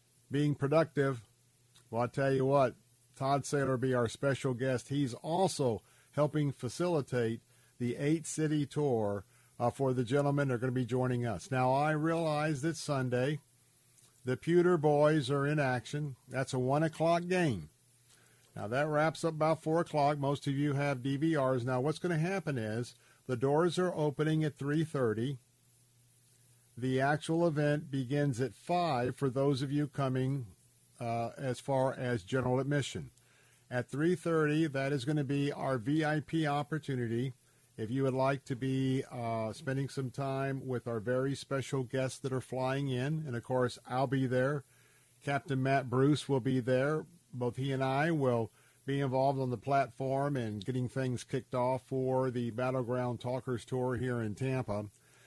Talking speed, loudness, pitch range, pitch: 170 wpm, -33 LUFS, 125-145 Hz, 135 Hz